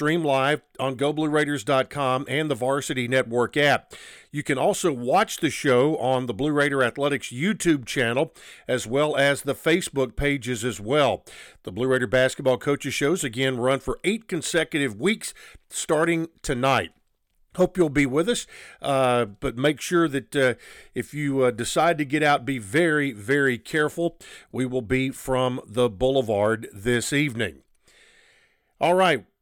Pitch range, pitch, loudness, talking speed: 130-150 Hz, 140 Hz, -23 LUFS, 155 wpm